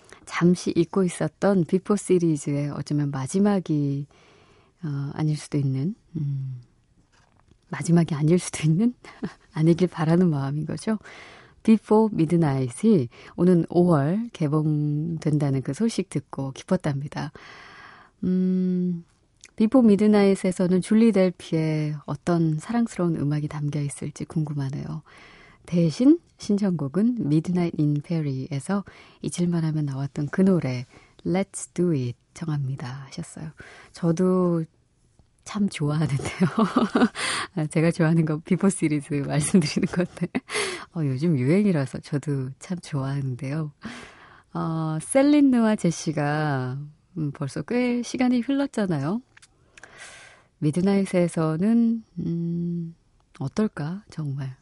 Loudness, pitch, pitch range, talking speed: -24 LUFS, 165 Hz, 145-190 Hz, 250 characters per minute